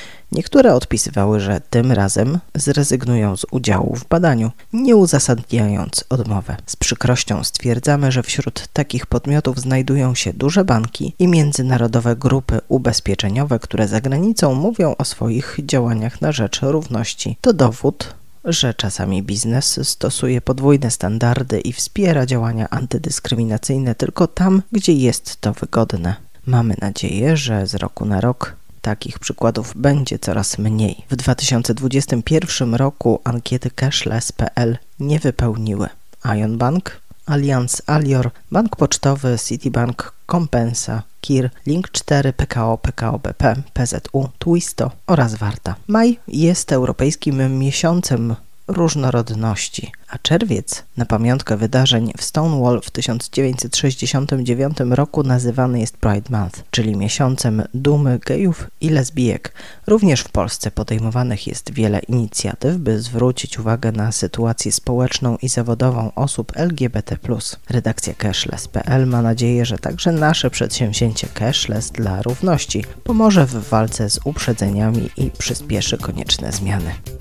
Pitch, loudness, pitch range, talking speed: 120 Hz, -18 LUFS, 110-140 Hz, 120 wpm